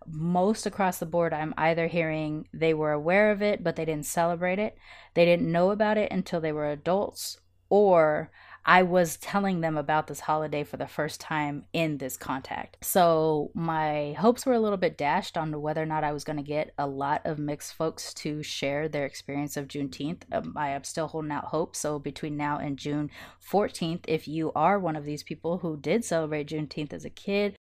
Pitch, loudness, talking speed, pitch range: 155 Hz, -28 LUFS, 205 wpm, 150-175 Hz